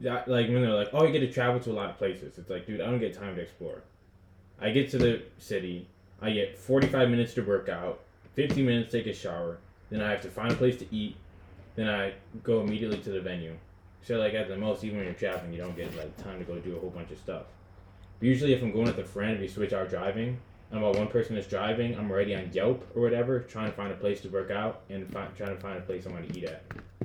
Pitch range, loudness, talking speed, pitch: 95-115 Hz, -31 LUFS, 275 wpm, 105 Hz